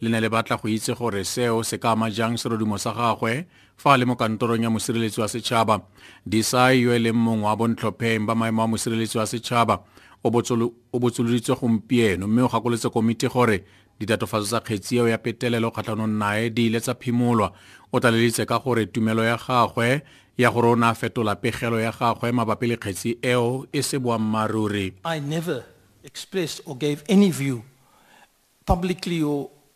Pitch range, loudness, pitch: 110-125 Hz, -23 LUFS, 115 Hz